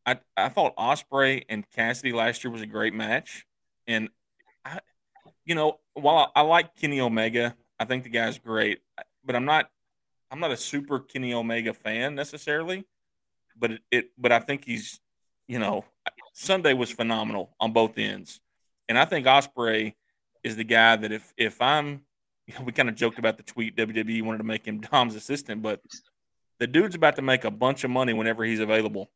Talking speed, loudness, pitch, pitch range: 185 wpm, -25 LUFS, 120 Hz, 110-135 Hz